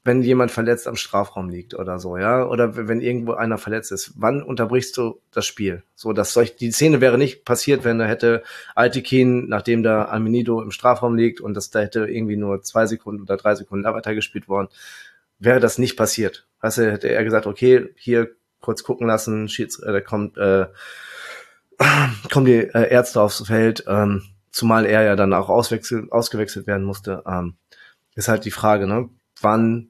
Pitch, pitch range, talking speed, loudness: 110 Hz, 105-120 Hz, 185 wpm, -19 LUFS